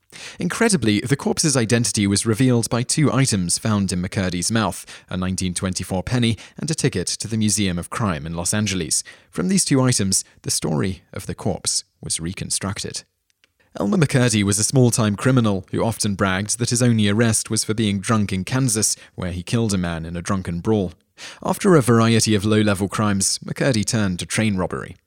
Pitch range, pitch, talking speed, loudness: 95-120 Hz, 105 Hz, 190 wpm, -20 LUFS